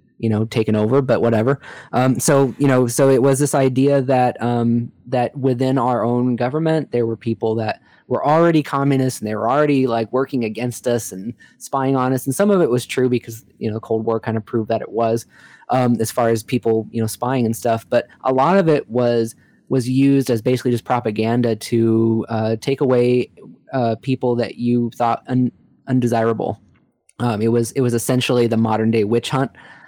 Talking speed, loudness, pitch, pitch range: 205 wpm, -18 LUFS, 120 Hz, 115-130 Hz